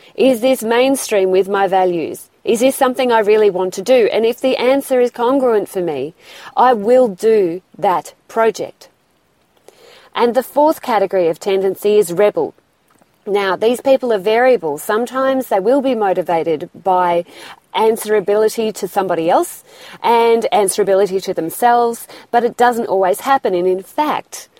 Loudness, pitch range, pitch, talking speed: -15 LUFS, 195-255 Hz, 220 Hz, 150 wpm